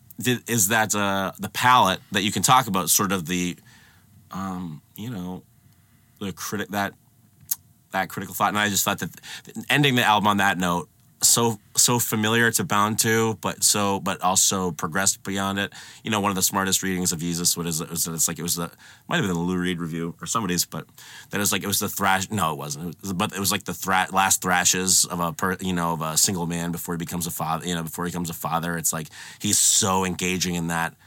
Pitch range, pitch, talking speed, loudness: 85-105 Hz, 95 Hz, 240 wpm, -22 LUFS